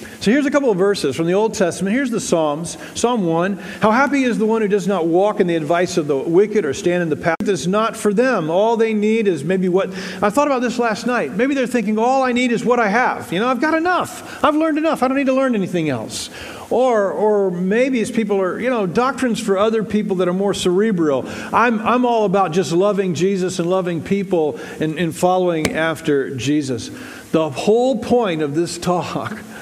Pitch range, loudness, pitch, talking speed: 175-235 Hz, -18 LUFS, 200 Hz, 230 wpm